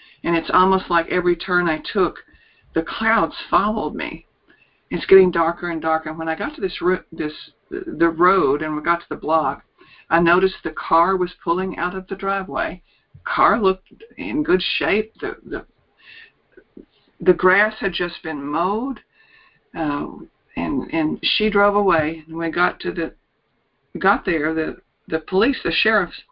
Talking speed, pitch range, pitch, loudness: 170 wpm, 165-200 Hz, 180 Hz, -20 LUFS